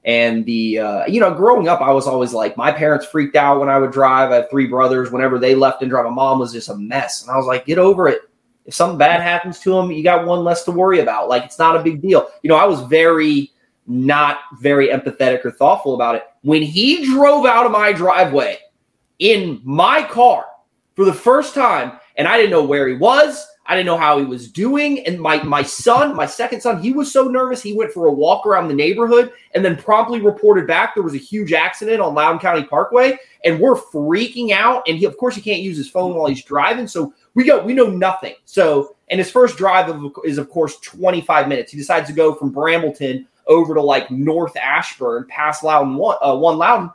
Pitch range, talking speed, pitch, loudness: 140-225 Hz, 235 wpm, 165 Hz, -15 LUFS